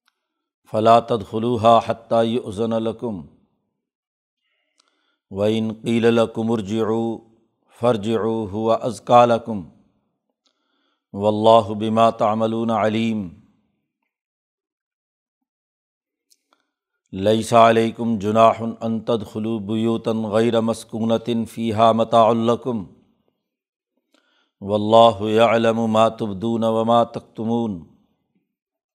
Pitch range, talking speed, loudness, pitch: 110-115 Hz, 50 wpm, -19 LUFS, 115 Hz